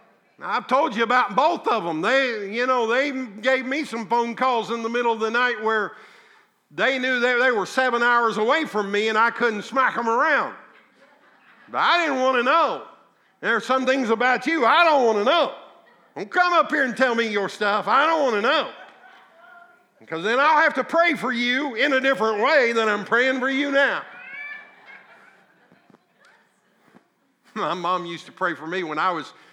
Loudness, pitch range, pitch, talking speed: -21 LUFS, 225-270 Hz, 250 Hz, 195 wpm